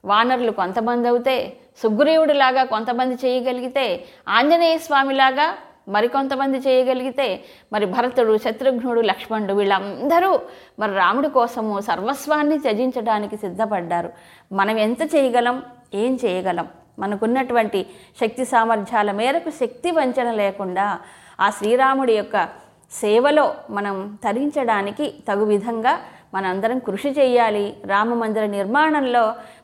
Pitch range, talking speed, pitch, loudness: 205-265 Hz, 95 wpm, 235 Hz, -20 LUFS